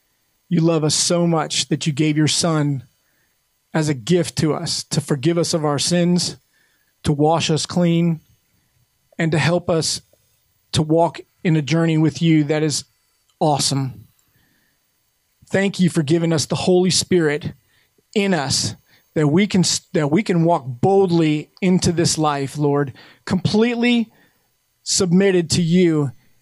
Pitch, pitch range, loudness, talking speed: 160 Hz, 145-175 Hz, -18 LUFS, 150 wpm